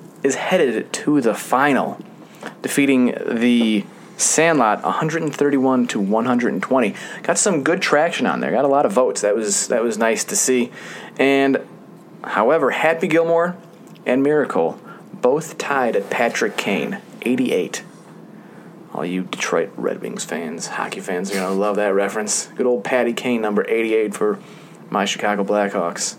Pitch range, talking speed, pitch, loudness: 105-170 Hz, 145 wpm, 130 Hz, -19 LUFS